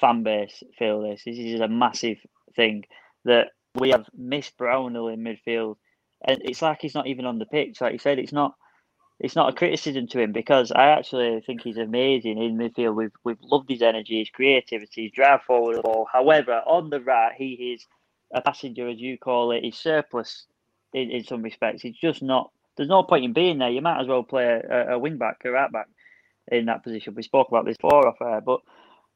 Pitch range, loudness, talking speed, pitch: 115-135 Hz, -23 LUFS, 210 wpm, 125 Hz